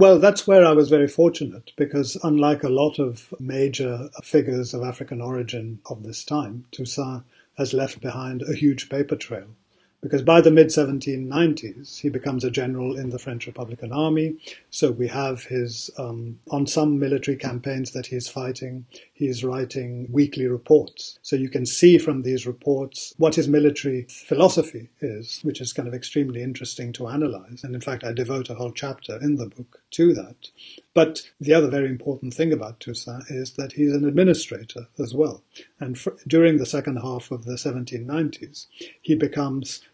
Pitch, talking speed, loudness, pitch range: 135 Hz, 175 wpm, -22 LUFS, 125-150 Hz